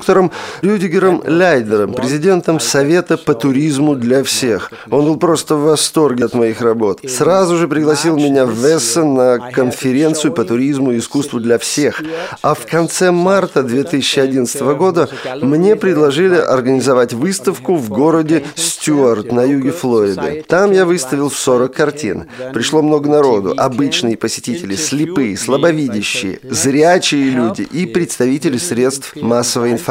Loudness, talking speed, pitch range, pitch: -13 LUFS, 130 wpm, 125-165 Hz, 145 Hz